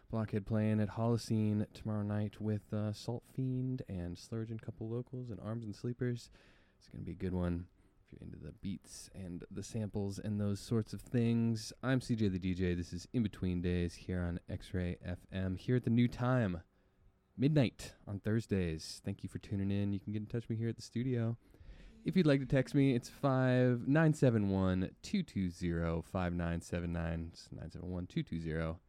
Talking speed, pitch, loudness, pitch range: 180 wpm, 105 Hz, -37 LUFS, 90-120 Hz